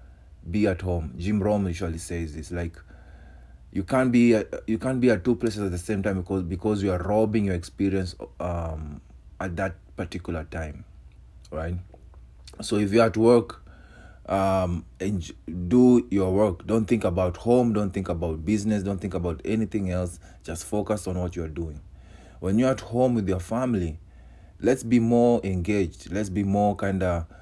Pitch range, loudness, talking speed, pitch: 85-105 Hz, -25 LUFS, 175 wpm, 95 Hz